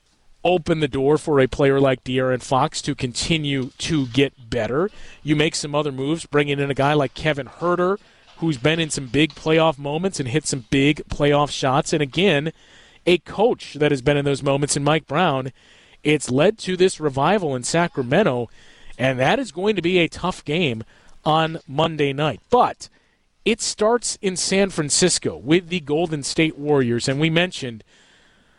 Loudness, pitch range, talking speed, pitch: -20 LUFS, 140-170 Hz, 180 wpm, 150 Hz